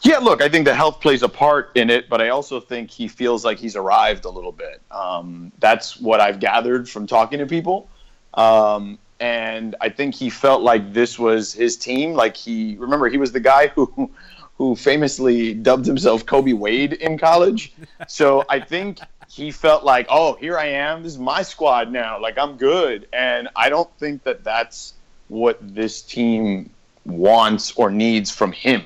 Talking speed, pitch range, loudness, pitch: 190 wpm, 115-155 Hz, -18 LUFS, 130 Hz